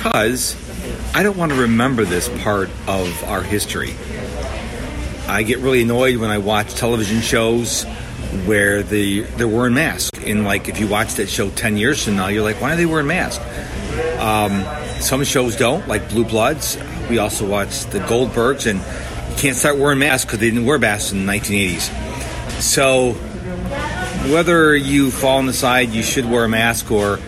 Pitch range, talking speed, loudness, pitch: 100-130 Hz, 180 wpm, -17 LUFS, 115 Hz